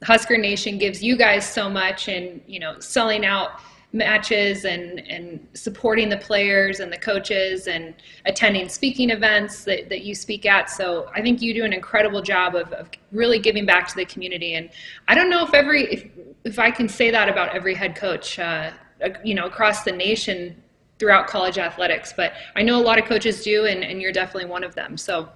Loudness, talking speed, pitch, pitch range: -20 LUFS, 205 wpm, 205 Hz, 190-225 Hz